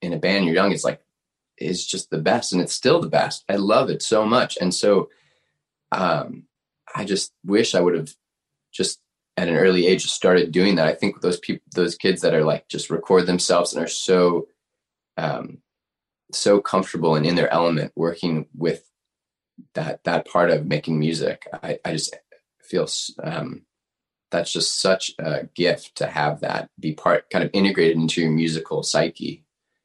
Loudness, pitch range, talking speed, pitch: -21 LUFS, 80-90 Hz, 180 wpm, 85 Hz